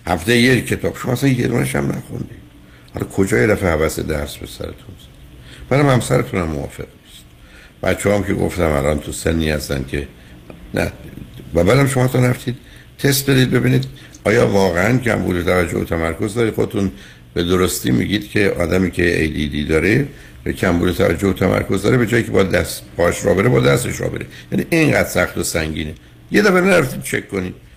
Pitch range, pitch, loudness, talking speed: 80-125 Hz, 95 Hz, -17 LUFS, 175 wpm